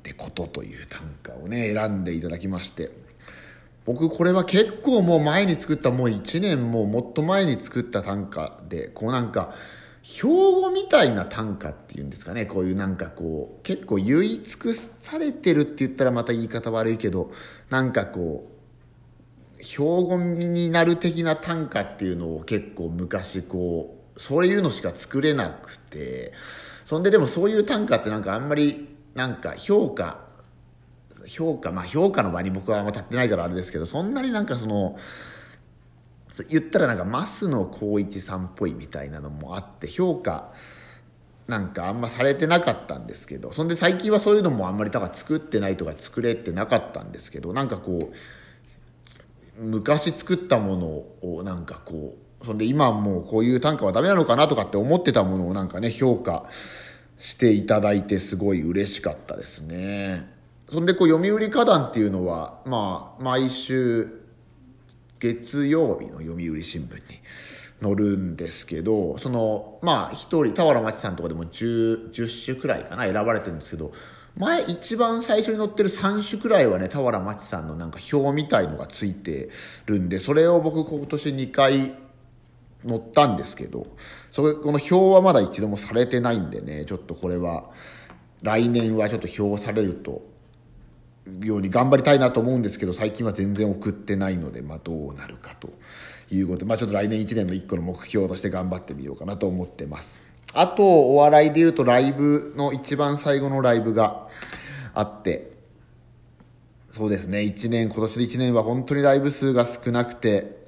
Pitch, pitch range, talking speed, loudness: 115 Hz, 95-145 Hz, 350 characters per minute, -23 LUFS